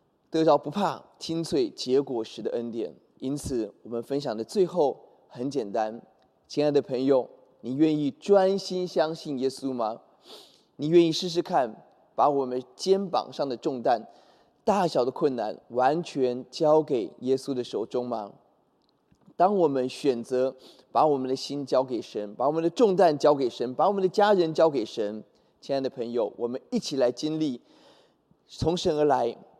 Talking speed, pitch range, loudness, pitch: 235 characters per minute, 125-165 Hz, -26 LUFS, 140 Hz